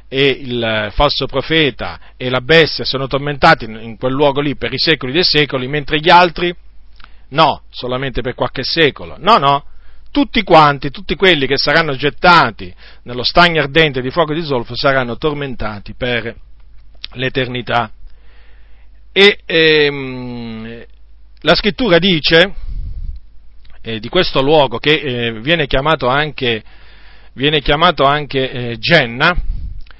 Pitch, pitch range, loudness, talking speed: 135 Hz, 115-155 Hz, -13 LUFS, 130 wpm